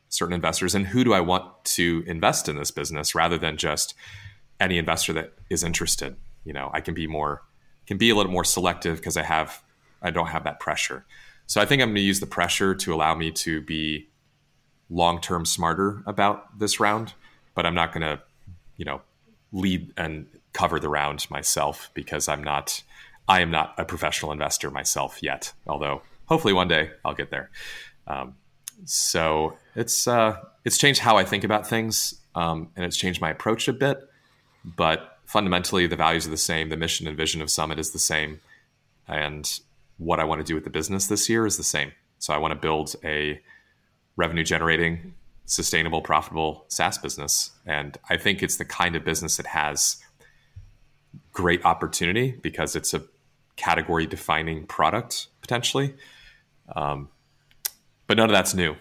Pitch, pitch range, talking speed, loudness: 85 Hz, 80-100 Hz, 180 wpm, -24 LUFS